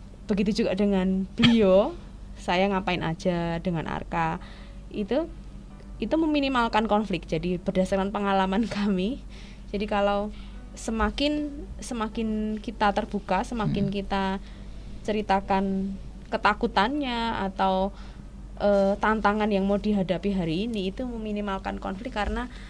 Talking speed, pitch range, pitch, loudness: 105 wpm, 190-215 Hz, 205 Hz, -26 LUFS